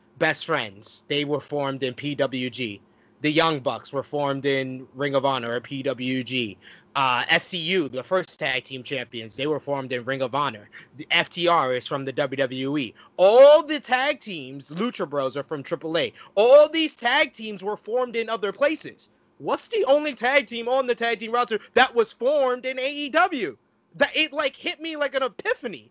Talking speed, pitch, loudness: 185 wpm, 165 Hz, -23 LUFS